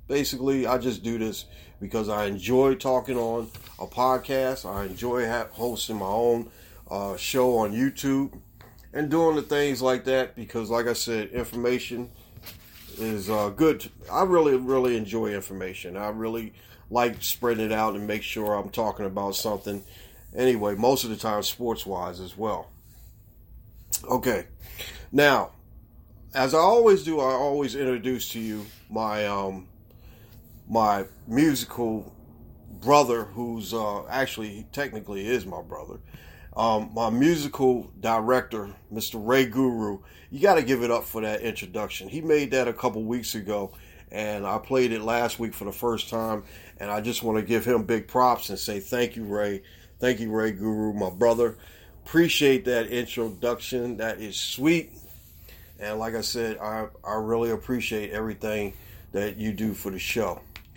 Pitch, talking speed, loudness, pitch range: 110 Hz, 155 wpm, -26 LUFS, 105-125 Hz